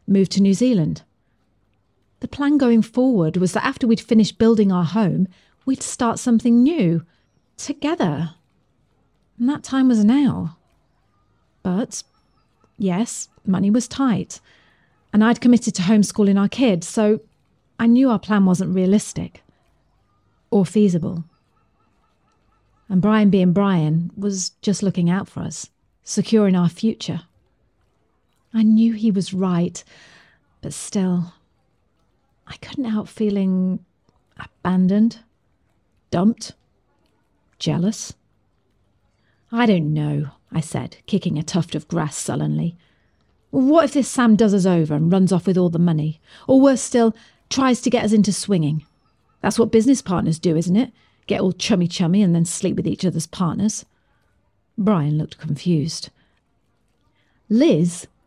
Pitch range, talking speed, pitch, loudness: 165-220 Hz, 135 wpm, 190 Hz, -19 LUFS